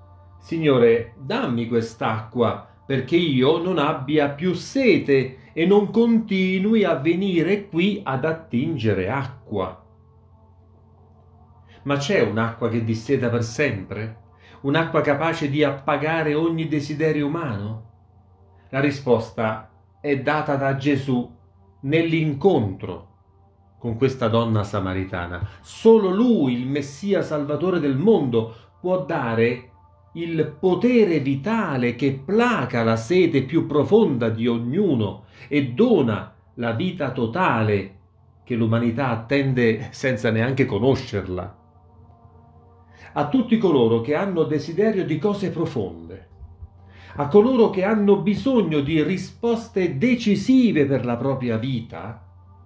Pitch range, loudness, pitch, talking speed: 105-160 Hz, -21 LUFS, 130 Hz, 110 wpm